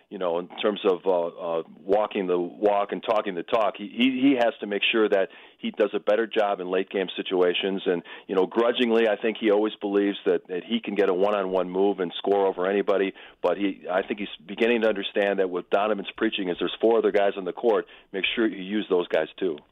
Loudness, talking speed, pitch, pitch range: -25 LUFS, 235 wpm, 100 Hz, 95-110 Hz